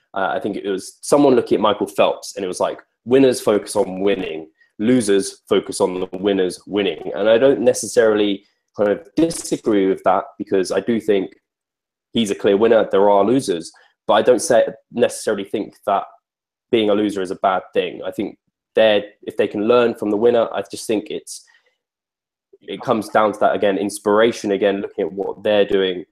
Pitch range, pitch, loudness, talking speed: 100-165 Hz, 105 Hz, -18 LUFS, 195 wpm